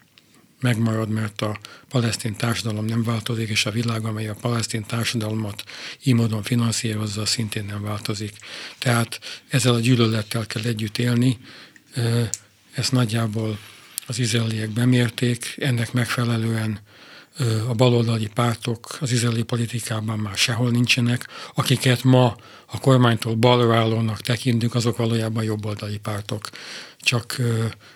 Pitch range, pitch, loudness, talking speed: 110-120 Hz, 115 Hz, -22 LUFS, 120 wpm